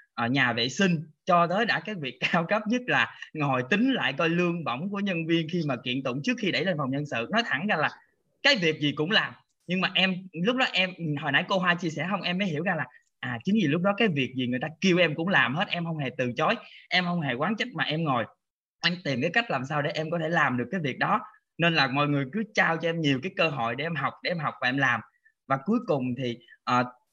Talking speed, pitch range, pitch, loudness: 290 wpm, 140-195 Hz, 165 Hz, -26 LUFS